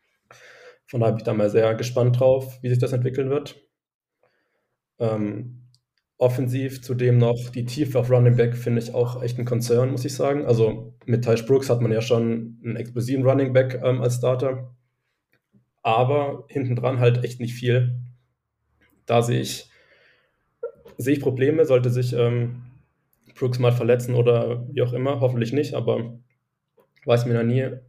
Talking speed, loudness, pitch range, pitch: 165 wpm, -22 LUFS, 120-130 Hz, 125 Hz